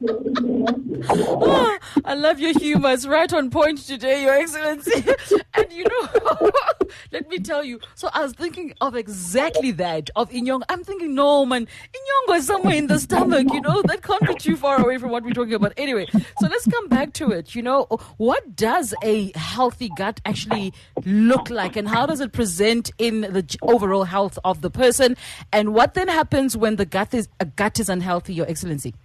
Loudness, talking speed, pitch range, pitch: -21 LUFS, 195 wpm, 210-290 Hz, 245 Hz